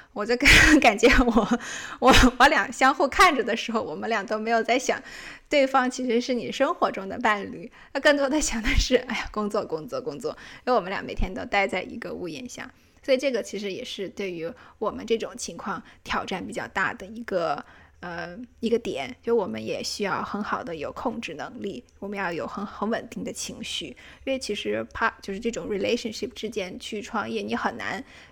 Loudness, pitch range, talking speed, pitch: -24 LUFS, 210-255 Hz, 315 characters per minute, 230 Hz